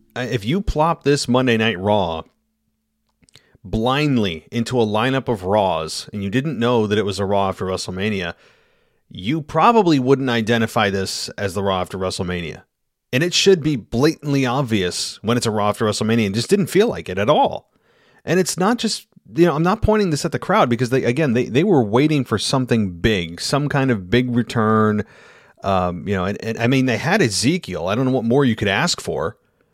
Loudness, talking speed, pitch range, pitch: -19 LUFS, 205 wpm, 105-140 Hz, 120 Hz